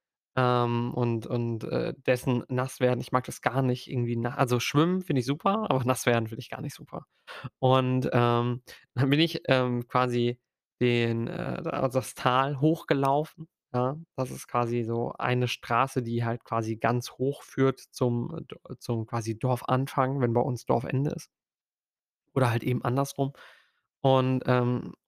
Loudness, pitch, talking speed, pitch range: -28 LUFS, 125 Hz, 165 wpm, 120-135 Hz